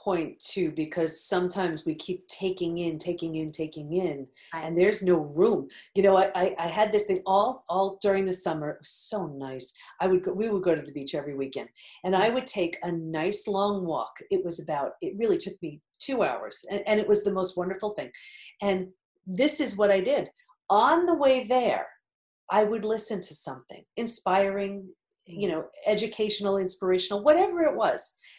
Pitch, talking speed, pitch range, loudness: 190 Hz, 195 wpm, 170-210 Hz, -27 LUFS